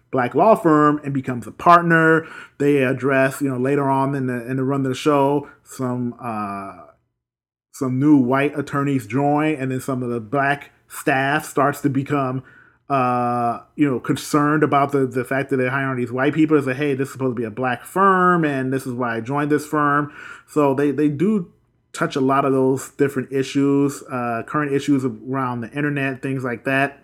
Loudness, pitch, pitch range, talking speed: -20 LUFS, 135 Hz, 130-145 Hz, 200 wpm